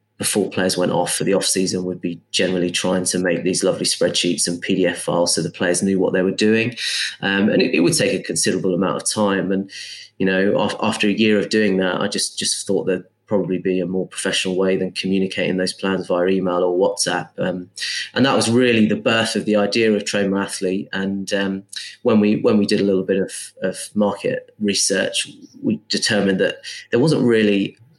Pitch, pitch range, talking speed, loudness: 95 Hz, 95-105 Hz, 210 wpm, -19 LUFS